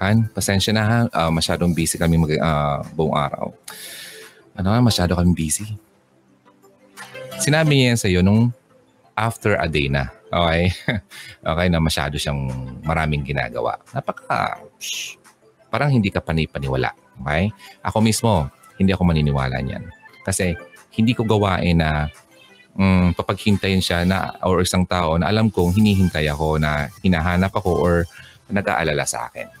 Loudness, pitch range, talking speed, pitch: -20 LUFS, 75-105 Hz, 145 wpm, 90 Hz